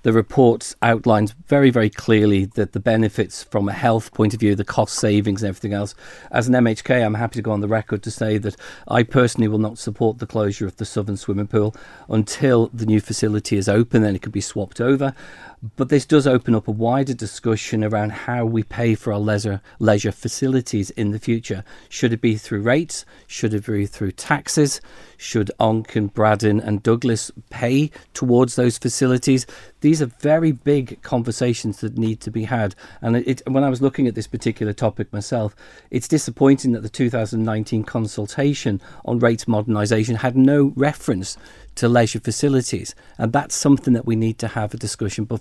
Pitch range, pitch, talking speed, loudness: 105-125 Hz, 115 Hz, 190 wpm, -20 LUFS